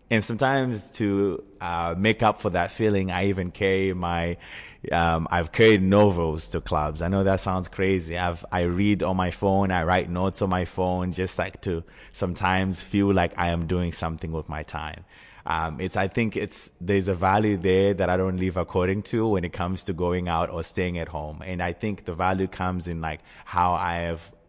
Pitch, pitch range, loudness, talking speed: 90 Hz, 85-100 Hz, -25 LUFS, 210 wpm